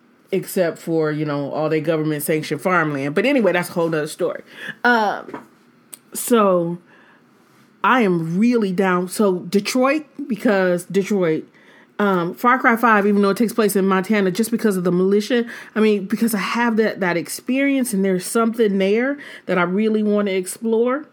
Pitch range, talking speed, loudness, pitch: 180-230 Hz, 170 wpm, -19 LUFS, 200 Hz